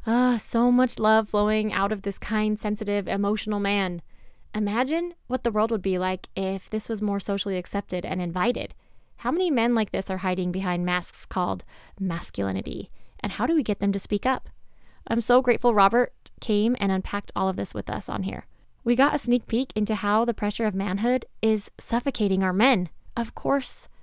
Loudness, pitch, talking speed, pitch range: -25 LUFS, 215 Hz, 195 wpm, 195-235 Hz